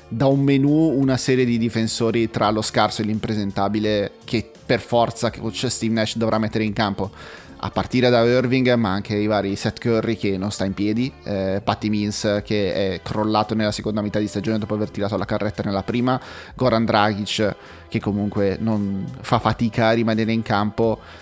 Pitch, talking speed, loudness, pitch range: 110 Hz, 185 wpm, -21 LUFS, 105-115 Hz